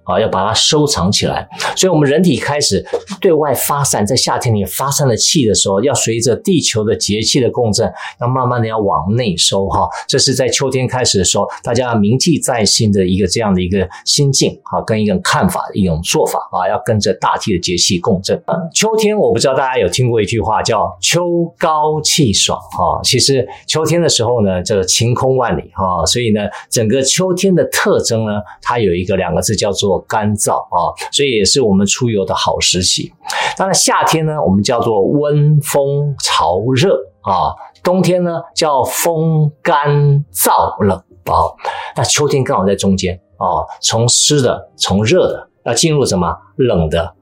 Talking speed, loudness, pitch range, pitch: 270 characters per minute, -13 LUFS, 100-150 Hz, 125 Hz